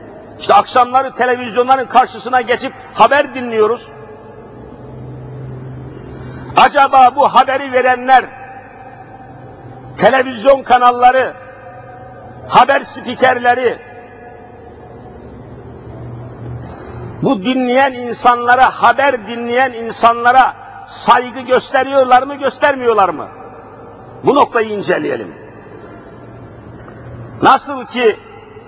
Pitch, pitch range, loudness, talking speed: 250 Hz, 225-265 Hz, -12 LUFS, 65 wpm